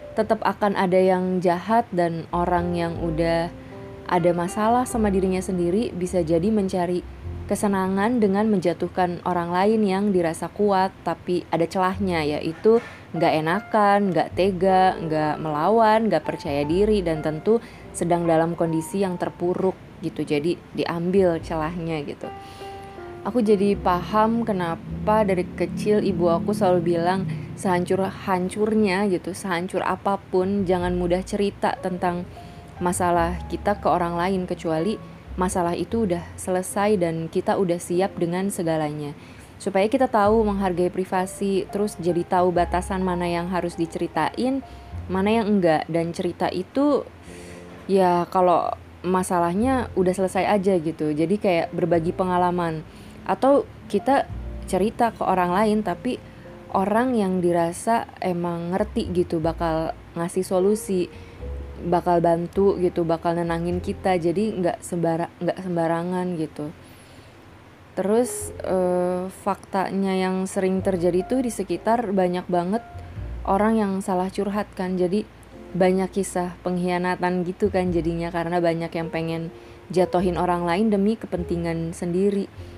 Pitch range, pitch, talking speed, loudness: 170-195 Hz, 180 Hz, 125 wpm, -23 LUFS